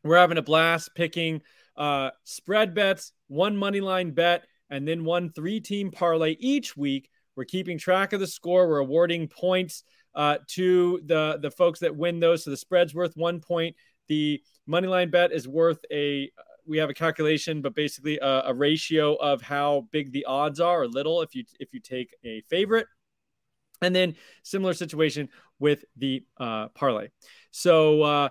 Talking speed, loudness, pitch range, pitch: 180 wpm, -25 LUFS, 145-180 Hz, 165 Hz